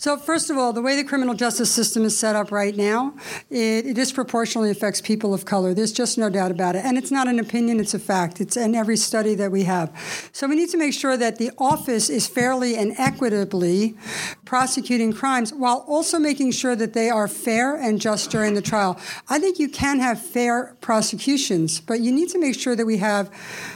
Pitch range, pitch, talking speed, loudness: 210-260 Hz, 230 Hz, 220 wpm, -21 LUFS